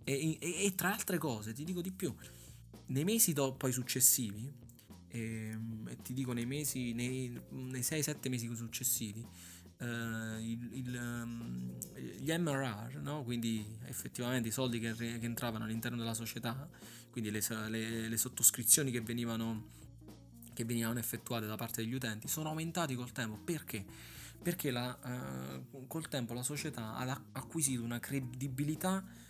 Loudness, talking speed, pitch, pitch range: -37 LUFS, 145 wpm, 120 Hz, 115-135 Hz